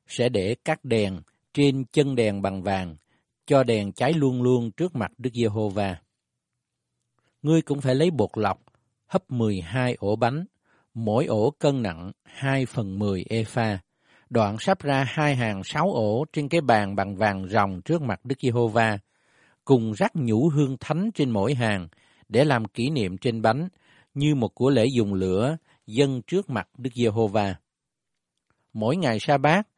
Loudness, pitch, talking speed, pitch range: -24 LUFS, 120 Hz, 165 wpm, 105-145 Hz